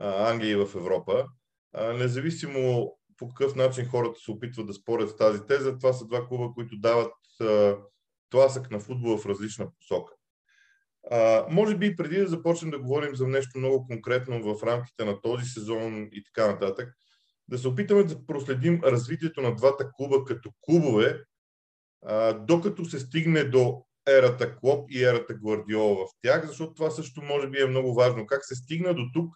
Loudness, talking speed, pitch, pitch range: -26 LUFS, 175 wpm, 130 Hz, 115-150 Hz